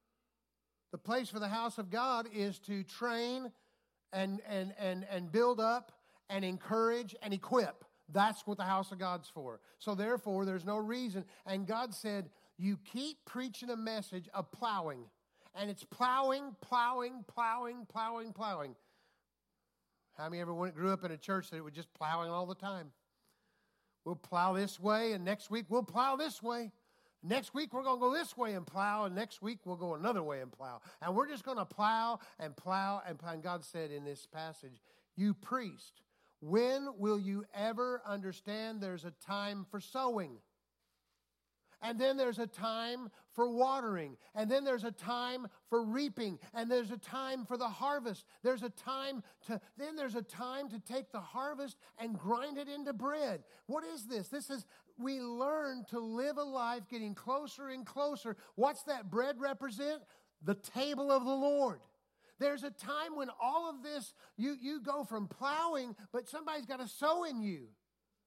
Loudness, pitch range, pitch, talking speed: -38 LUFS, 195-255 Hz, 225 Hz, 180 wpm